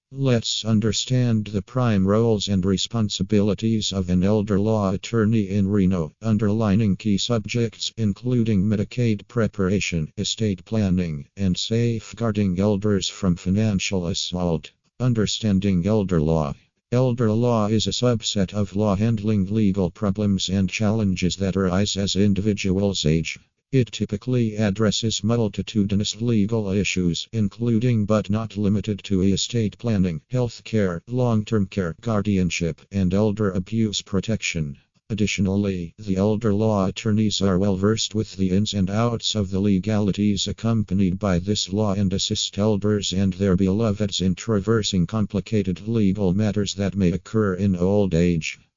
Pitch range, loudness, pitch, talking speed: 95-110 Hz, -22 LUFS, 100 Hz, 135 wpm